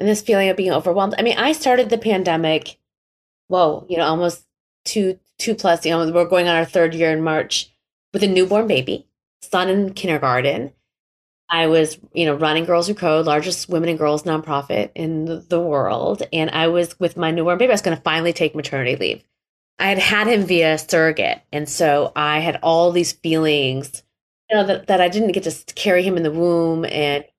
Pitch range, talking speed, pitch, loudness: 155-185 Hz, 210 wpm, 170 Hz, -18 LUFS